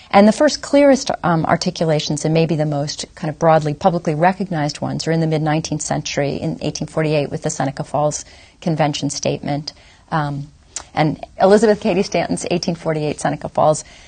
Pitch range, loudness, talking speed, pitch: 150-180 Hz, -18 LUFS, 160 wpm, 155 Hz